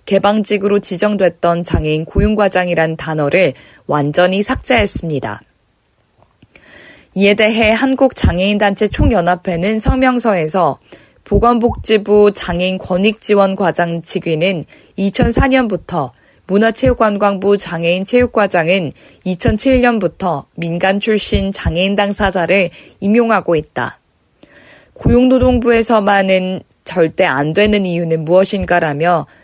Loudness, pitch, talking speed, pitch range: -14 LUFS, 195 Hz, 265 characters per minute, 175-215 Hz